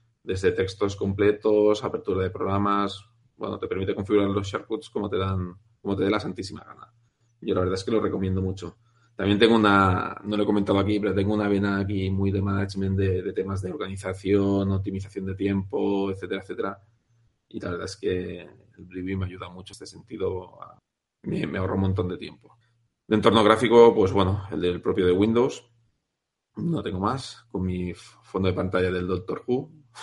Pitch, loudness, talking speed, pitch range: 100 Hz, -25 LUFS, 190 wpm, 95-110 Hz